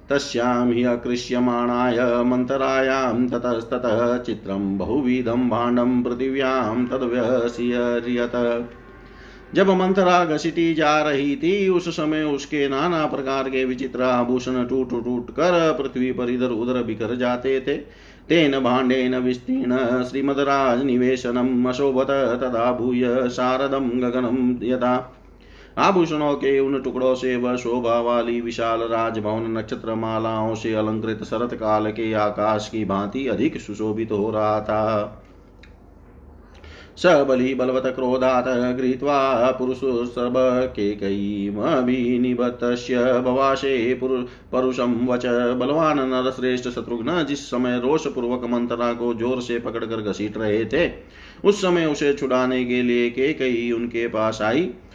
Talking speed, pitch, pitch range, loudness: 115 wpm, 125 Hz, 115-130 Hz, -21 LUFS